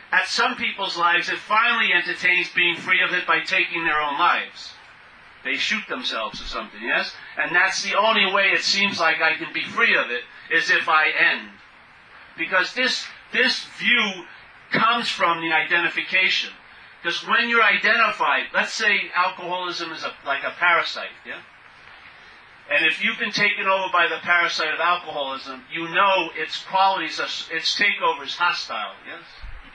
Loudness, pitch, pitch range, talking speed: -20 LUFS, 180 Hz, 170-205 Hz, 165 wpm